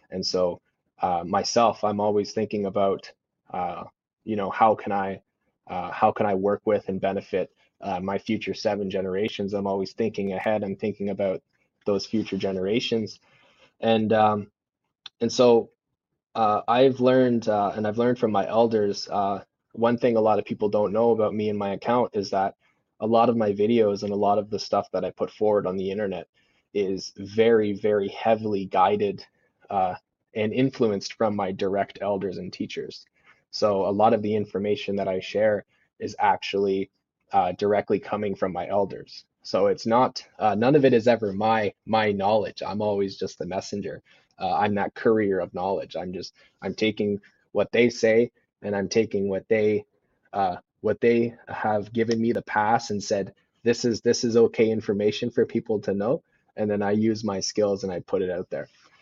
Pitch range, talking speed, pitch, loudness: 100-115 Hz, 185 wpm, 105 Hz, -25 LUFS